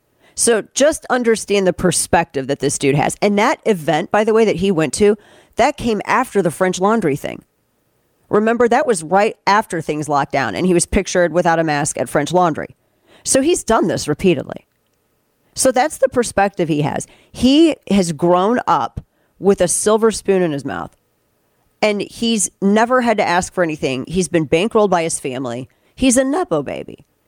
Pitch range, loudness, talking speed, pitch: 165-225 Hz, -16 LUFS, 185 wpm, 195 Hz